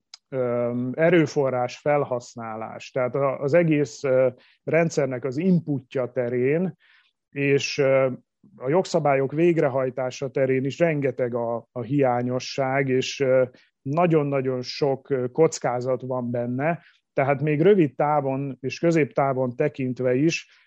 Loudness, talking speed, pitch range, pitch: -23 LUFS, 95 wpm, 125-150 Hz, 135 Hz